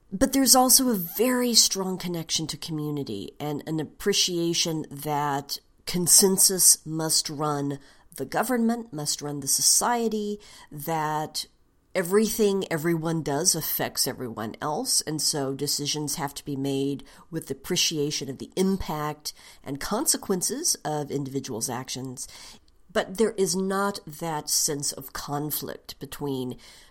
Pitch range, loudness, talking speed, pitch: 145-190 Hz, -24 LUFS, 125 wpm, 155 Hz